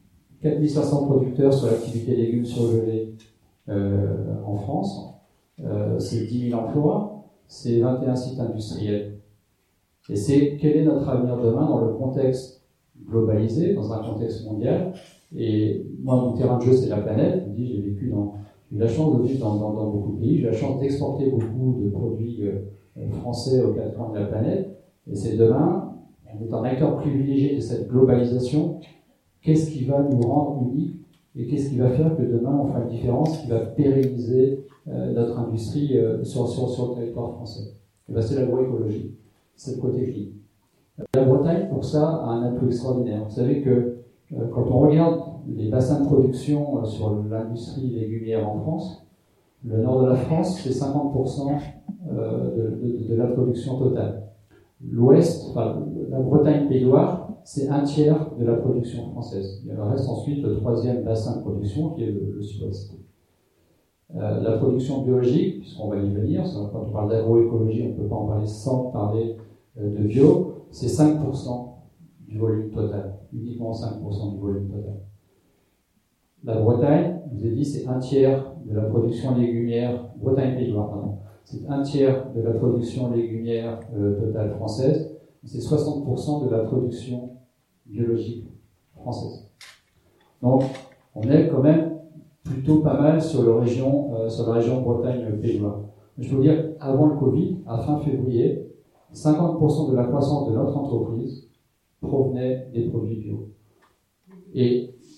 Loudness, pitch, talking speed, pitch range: -23 LUFS, 125 Hz, 160 wpm, 110-140 Hz